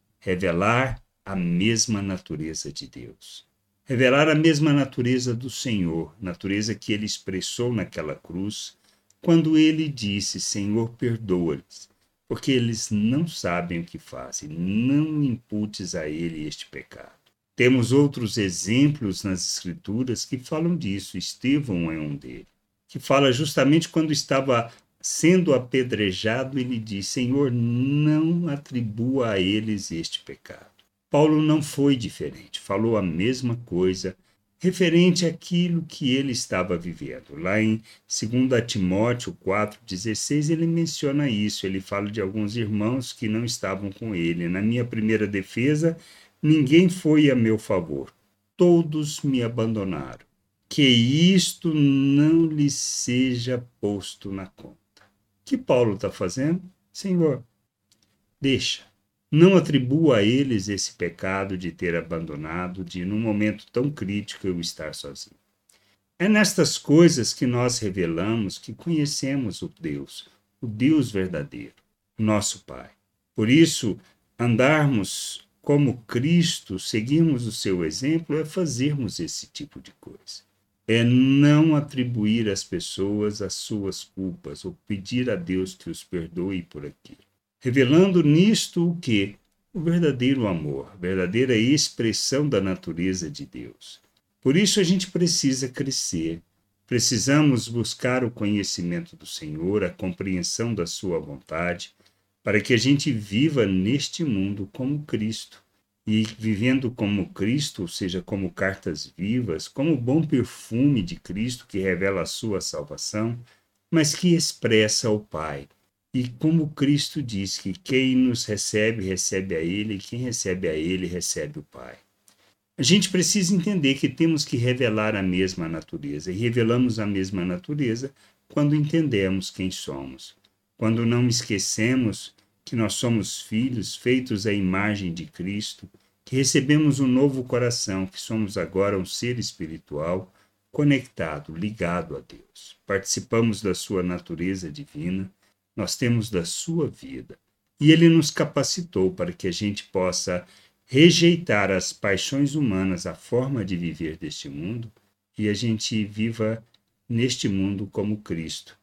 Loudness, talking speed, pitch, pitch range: -23 LUFS, 135 wpm, 110 Hz, 95-140 Hz